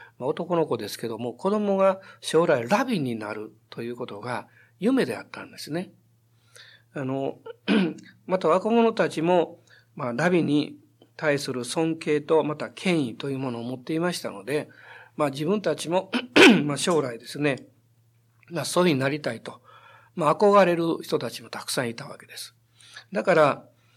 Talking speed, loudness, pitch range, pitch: 300 characters per minute, -24 LUFS, 120-175 Hz, 150 Hz